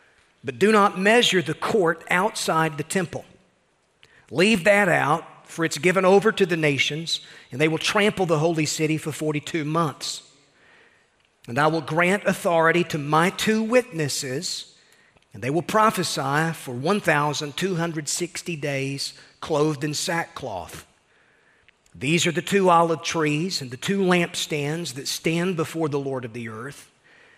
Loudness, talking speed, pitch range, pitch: -22 LUFS, 145 wpm, 150-185 Hz, 165 Hz